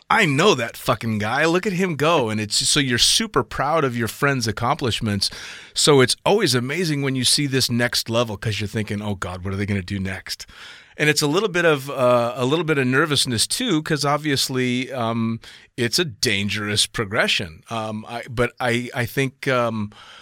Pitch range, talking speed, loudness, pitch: 110-140 Hz, 200 wpm, -20 LUFS, 120 Hz